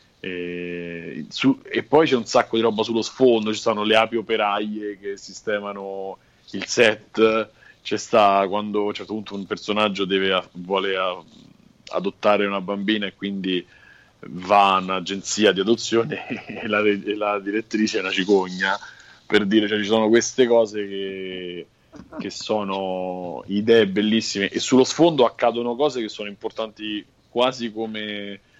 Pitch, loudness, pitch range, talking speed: 105 Hz, -21 LUFS, 95-110 Hz, 155 wpm